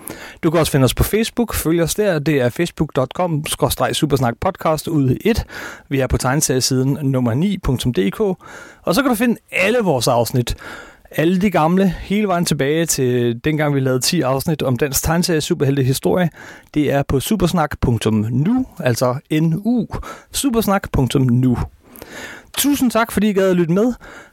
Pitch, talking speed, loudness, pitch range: 155 Hz, 150 wpm, -17 LUFS, 130-190 Hz